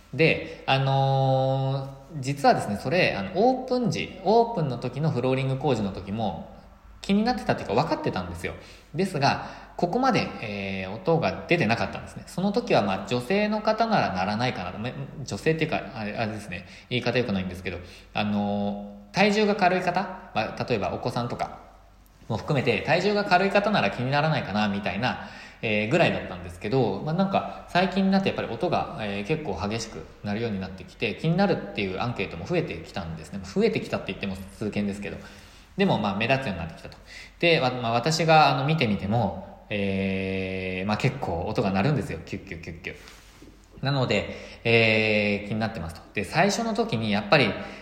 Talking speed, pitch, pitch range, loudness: 410 characters per minute, 115 Hz, 100-160 Hz, -25 LUFS